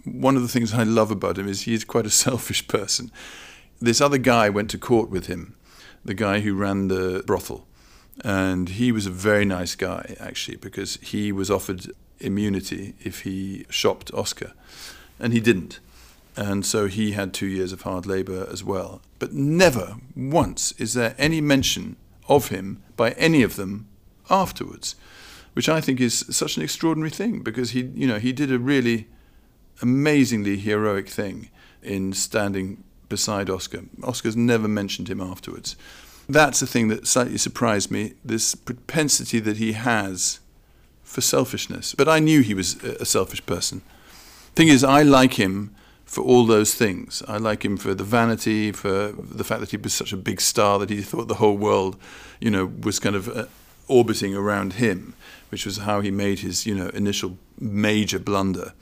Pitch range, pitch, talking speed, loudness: 95-120 Hz, 105 Hz, 180 wpm, -22 LUFS